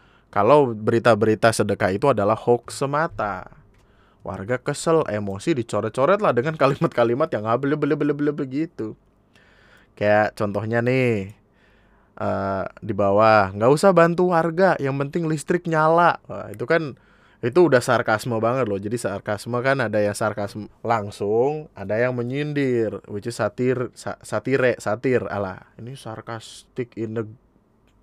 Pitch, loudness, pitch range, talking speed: 120 Hz, -21 LUFS, 105-145 Hz, 130 wpm